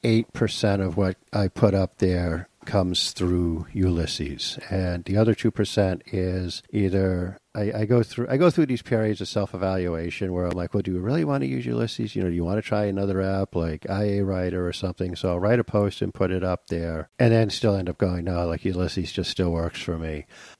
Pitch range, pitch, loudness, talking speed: 90-105 Hz, 95 Hz, -25 LUFS, 230 wpm